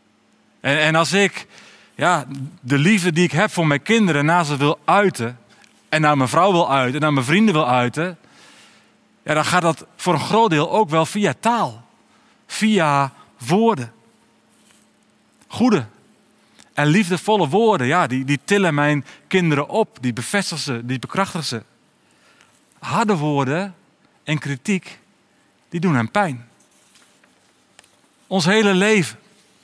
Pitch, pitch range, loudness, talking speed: 170 Hz, 140-200 Hz, -18 LUFS, 140 wpm